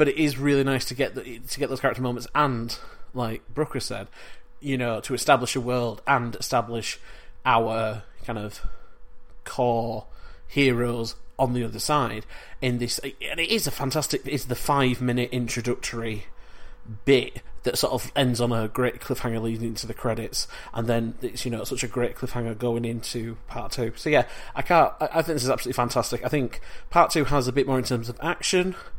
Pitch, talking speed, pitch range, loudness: 125 Hz, 195 wpm, 115-135 Hz, -26 LUFS